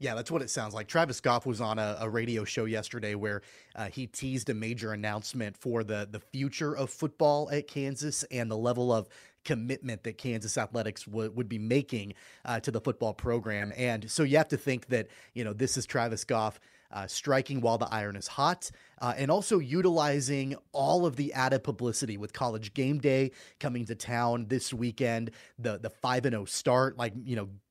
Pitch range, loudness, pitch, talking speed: 110-135 Hz, -31 LUFS, 120 Hz, 205 wpm